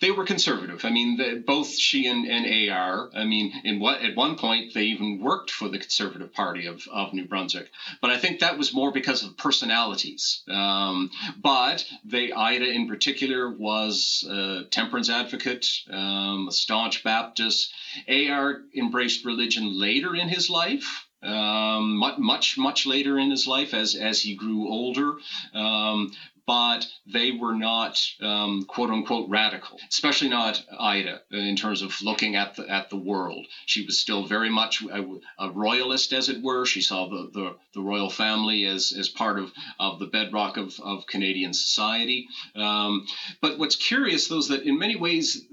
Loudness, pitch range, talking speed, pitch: -24 LUFS, 100-130 Hz, 175 wpm, 110 Hz